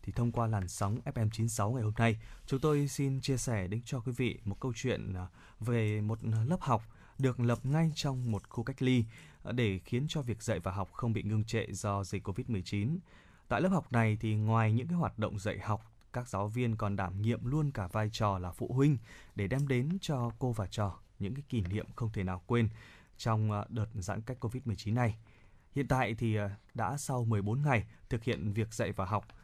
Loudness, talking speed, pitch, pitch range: -34 LUFS, 215 wpm, 115 Hz, 105-125 Hz